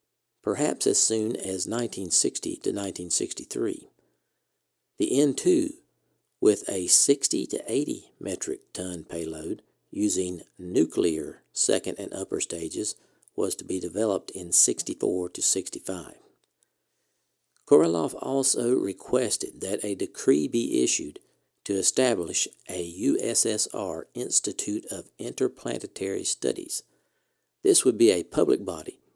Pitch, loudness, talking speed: 135 Hz, -26 LUFS, 110 wpm